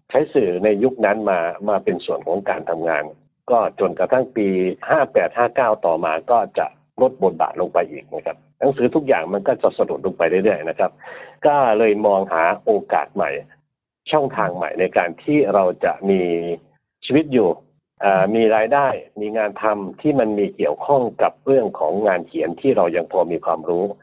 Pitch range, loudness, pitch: 95-130 Hz, -19 LUFS, 105 Hz